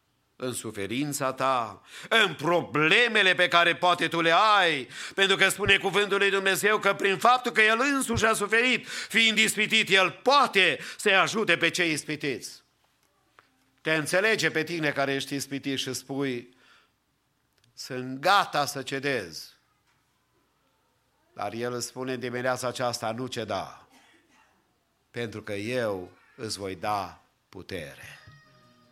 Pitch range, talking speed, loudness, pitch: 125-195 Hz, 130 wpm, -24 LUFS, 150 Hz